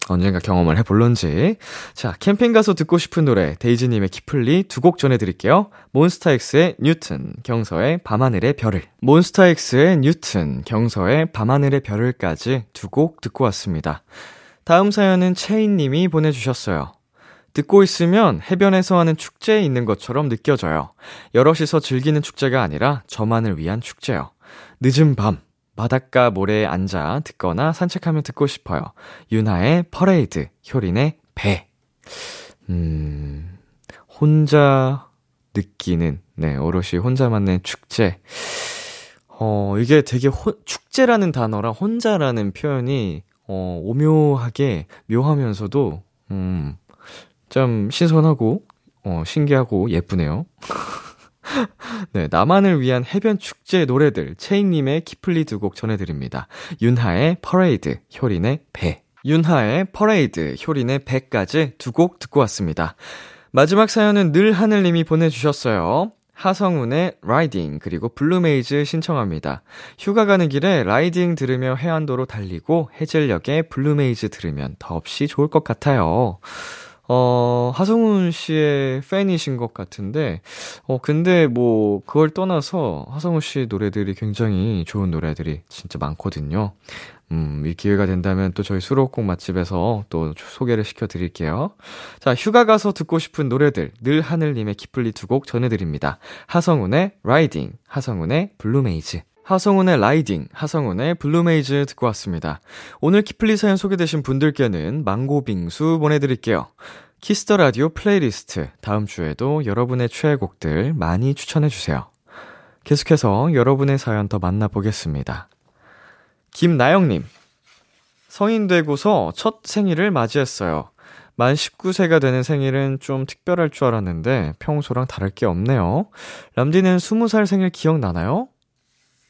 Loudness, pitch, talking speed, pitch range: -19 LUFS, 135 Hz, 300 characters per minute, 105-165 Hz